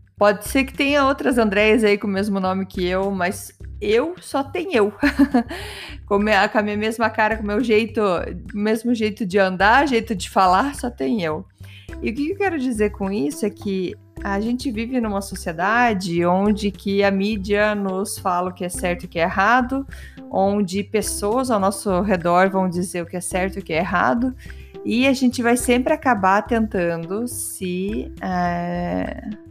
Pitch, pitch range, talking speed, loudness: 205 Hz, 185-235 Hz, 185 wpm, -20 LUFS